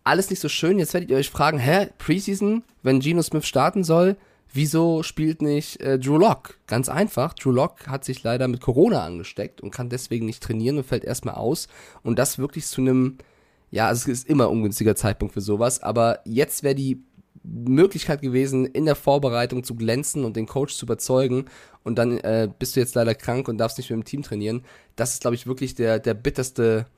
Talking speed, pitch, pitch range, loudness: 210 wpm, 130 Hz, 115-150 Hz, -23 LUFS